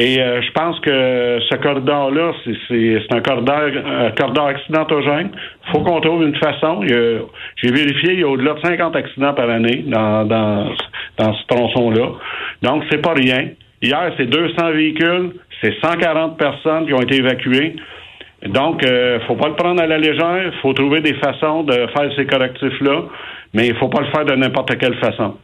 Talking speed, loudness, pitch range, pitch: 195 wpm, -16 LUFS, 125-155 Hz, 140 Hz